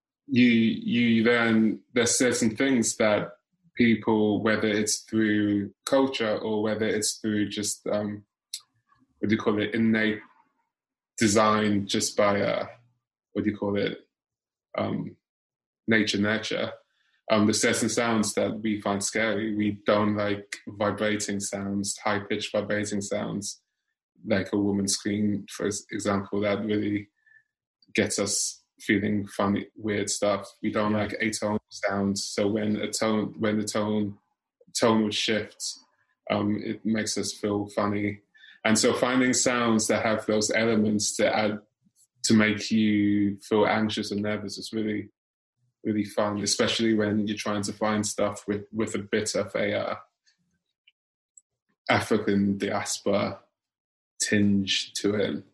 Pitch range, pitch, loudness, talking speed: 105-110 Hz, 105 Hz, -26 LUFS, 135 wpm